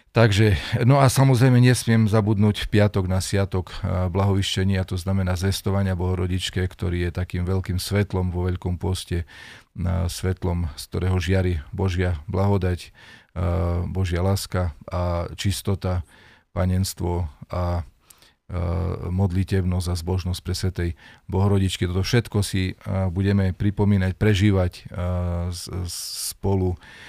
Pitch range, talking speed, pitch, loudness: 90-100 Hz, 110 wpm, 95 Hz, -23 LUFS